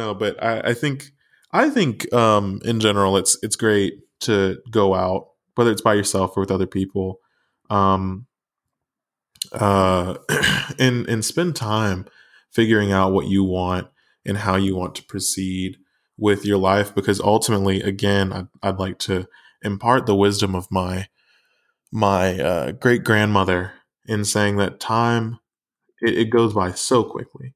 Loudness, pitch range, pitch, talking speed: -20 LUFS, 95-110 Hz, 100 Hz, 150 wpm